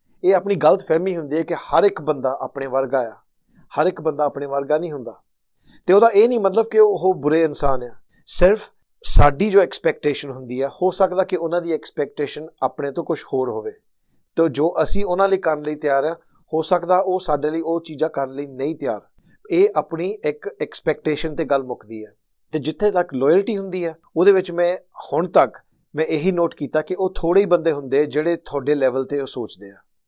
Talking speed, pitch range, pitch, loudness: 205 wpm, 140-185 Hz, 160 Hz, -20 LUFS